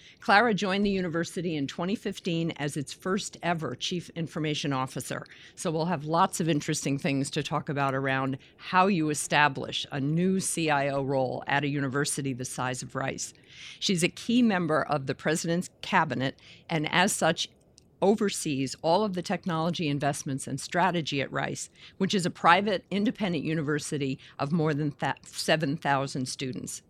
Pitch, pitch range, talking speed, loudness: 155 Hz, 140-180 Hz, 155 wpm, -28 LUFS